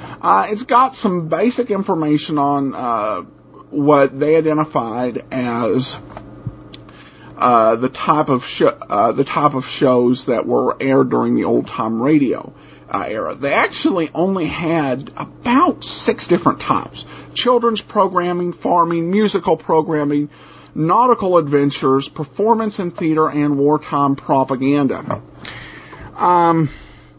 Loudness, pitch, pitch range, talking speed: -17 LUFS, 150 Hz, 135-175 Hz, 125 wpm